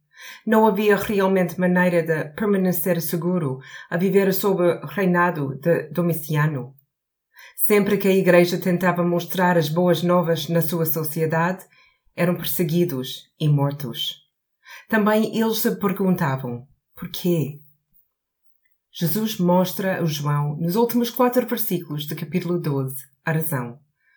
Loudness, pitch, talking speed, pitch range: -21 LUFS, 175 Hz, 120 wpm, 155-190 Hz